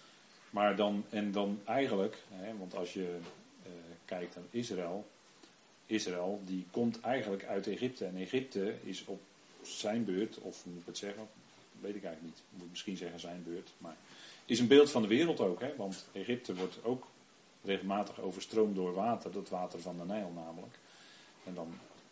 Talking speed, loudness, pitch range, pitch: 175 wpm, -36 LUFS, 90-110 Hz, 95 Hz